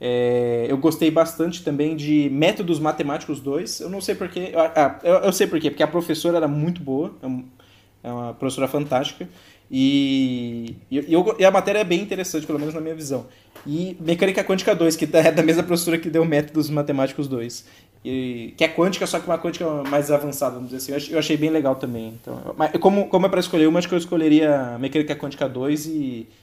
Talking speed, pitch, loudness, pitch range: 205 wpm, 150 Hz, -21 LUFS, 130-165 Hz